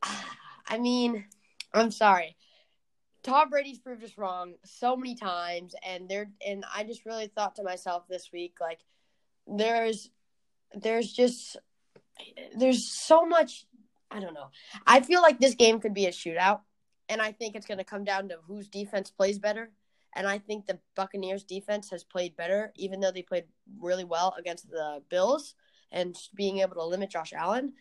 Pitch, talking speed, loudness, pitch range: 205 Hz, 175 wpm, -28 LUFS, 185-230 Hz